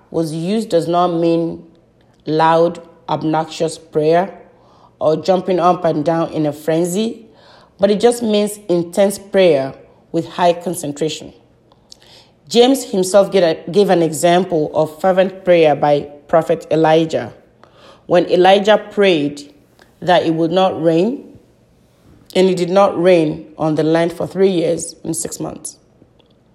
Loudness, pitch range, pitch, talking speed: -15 LUFS, 160-185 Hz, 170 Hz, 130 wpm